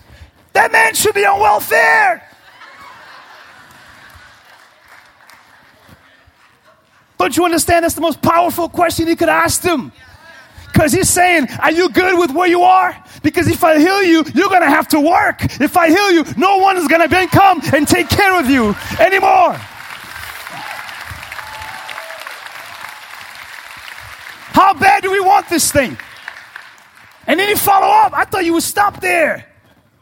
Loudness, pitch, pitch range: -12 LUFS, 350 Hz, 330-385 Hz